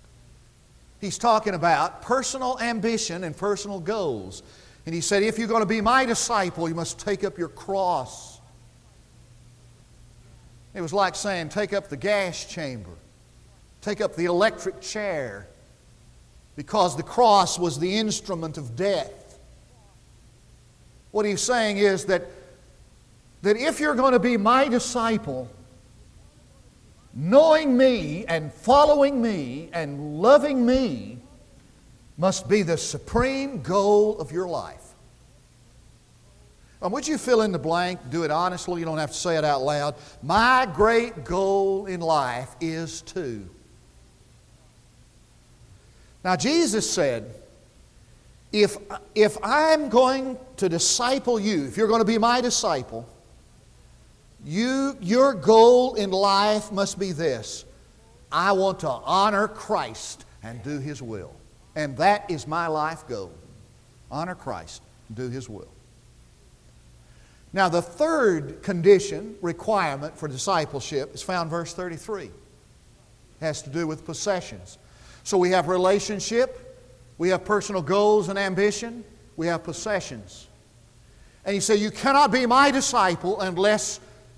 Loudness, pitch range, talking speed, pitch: -23 LUFS, 145-215 Hz, 130 wpm, 185 Hz